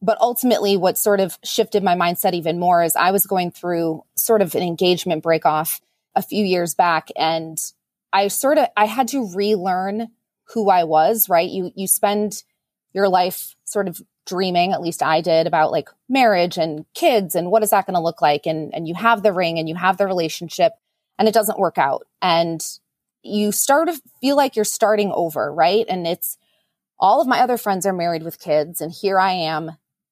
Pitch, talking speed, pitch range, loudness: 190 Hz, 205 wpm, 170-215 Hz, -19 LUFS